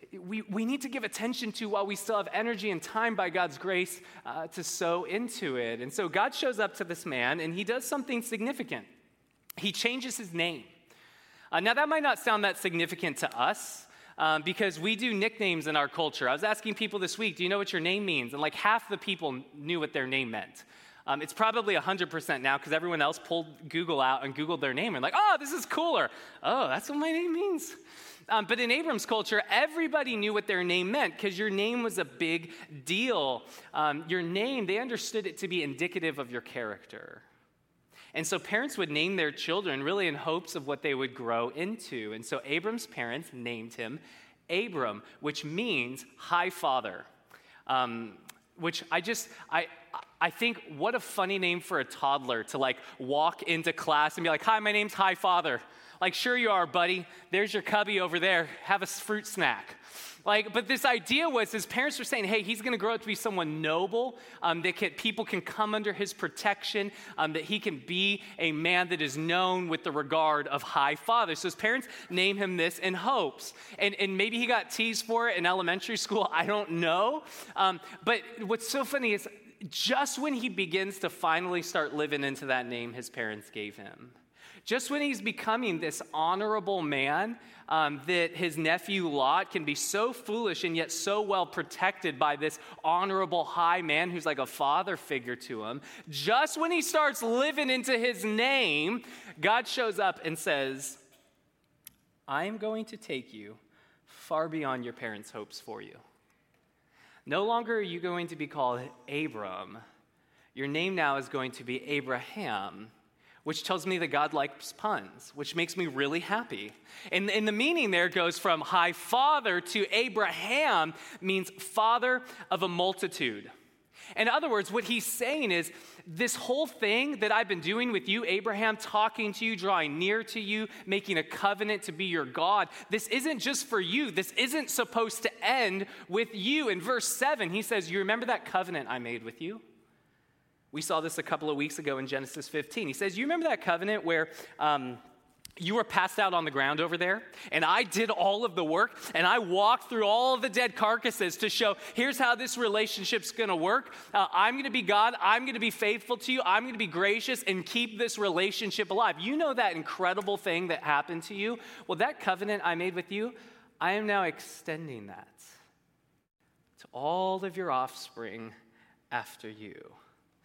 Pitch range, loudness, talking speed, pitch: 165-225 Hz, -30 LUFS, 195 wpm, 195 Hz